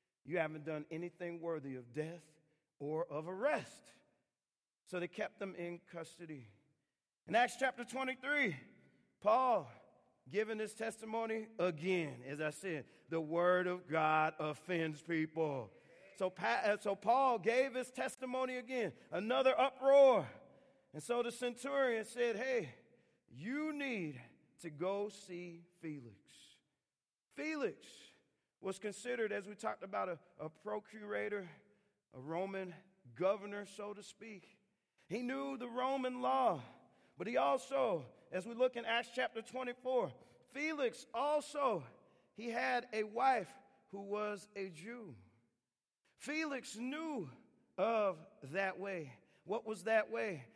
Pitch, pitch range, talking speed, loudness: 205 Hz, 170-245 Hz, 125 wpm, -39 LUFS